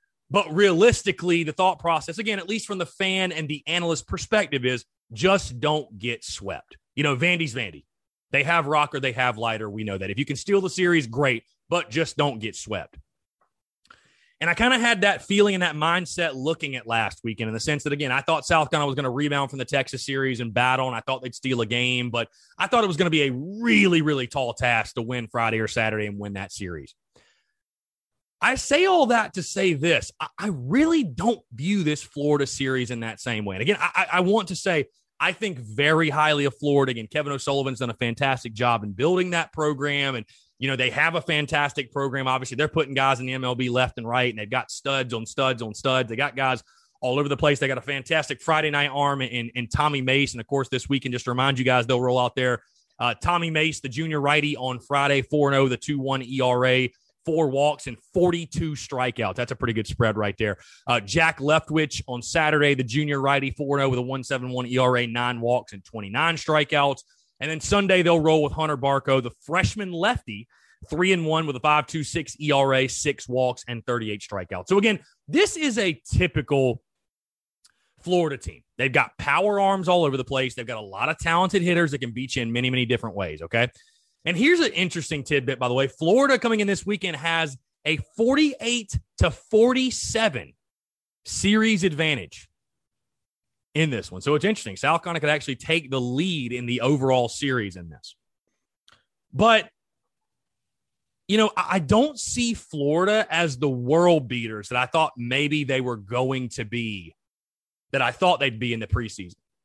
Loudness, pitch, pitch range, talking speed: -23 LUFS, 140 Hz, 125-165 Hz, 205 wpm